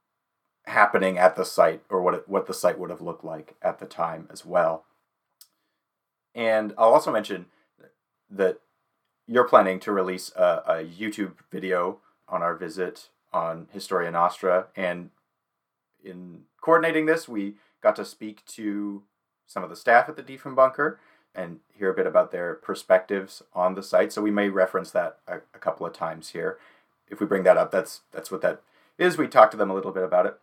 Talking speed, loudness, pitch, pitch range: 185 wpm, -24 LUFS, 100 Hz, 95-130 Hz